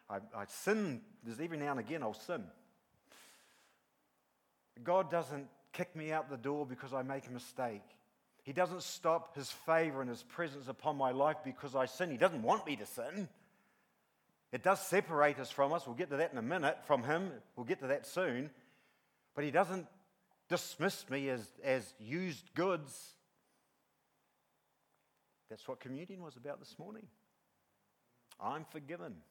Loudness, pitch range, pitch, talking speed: -38 LUFS, 135-180 Hz, 155 Hz, 165 wpm